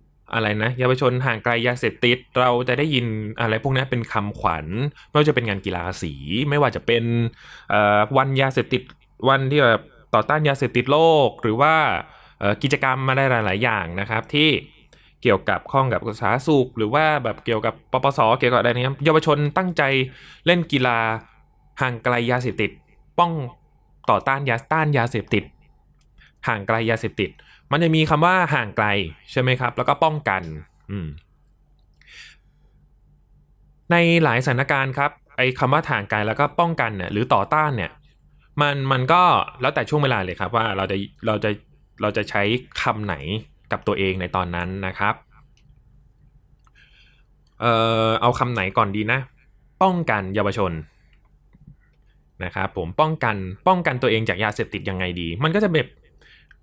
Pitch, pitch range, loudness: 120 Hz, 105-140 Hz, -21 LUFS